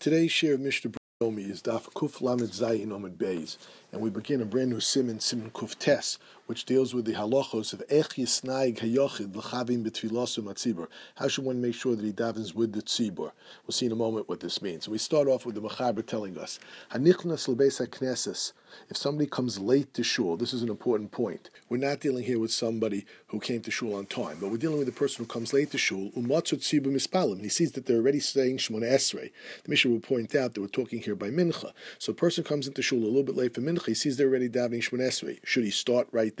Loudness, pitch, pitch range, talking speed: -29 LUFS, 125 Hz, 115-135 Hz, 235 wpm